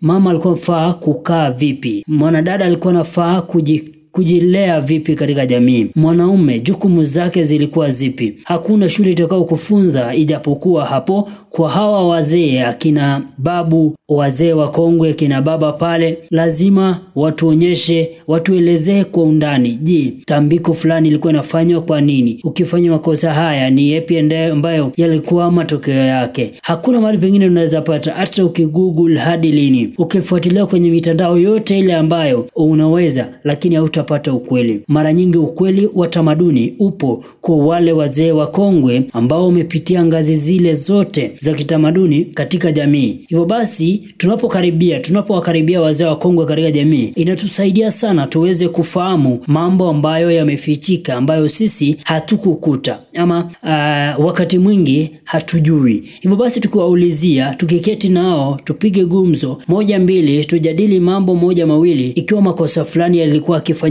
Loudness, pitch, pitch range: -13 LUFS, 165 Hz, 155-180 Hz